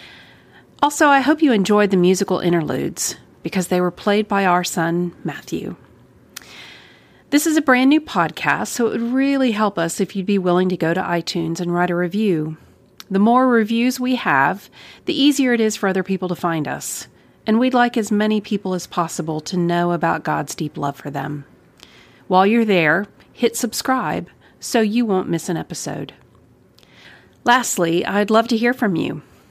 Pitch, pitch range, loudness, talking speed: 195 Hz, 175-235 Hz, -19 LUFS, 180 wpm